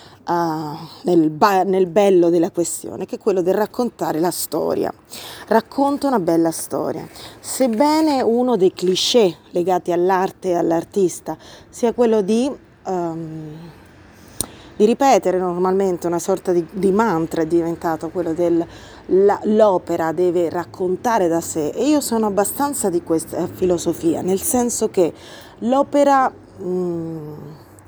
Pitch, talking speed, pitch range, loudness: 180 Hz, 125 wpm, 165-215 Hz, -19 LUFS